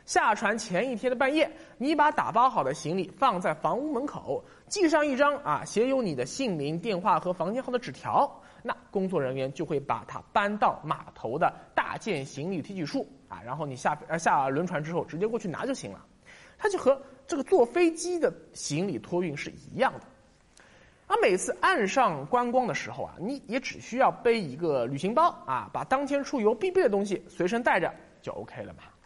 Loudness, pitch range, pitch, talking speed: -28 LUFS, 170-280 Hz, 235 Hz, 290 characters per minute